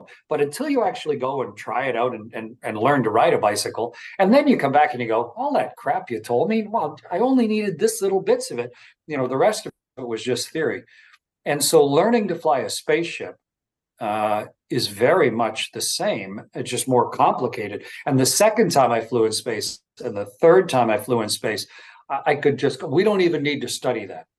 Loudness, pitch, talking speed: -21 LUFS, 150 Hz, 230 wpm